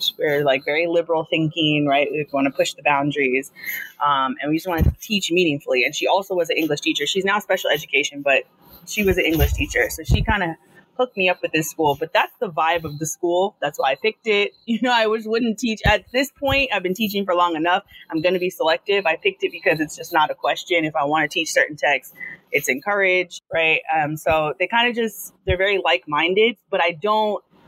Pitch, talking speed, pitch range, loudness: 180 Hz, 240 wpm, 155-205 Hz, -20 LUFS